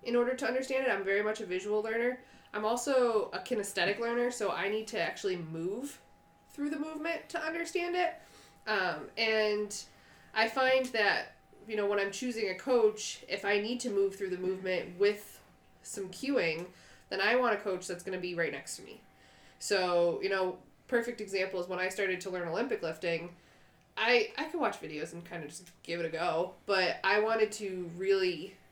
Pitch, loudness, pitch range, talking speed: 205 Hz, -32 LUFS, 185-245 Hz, 200 wpm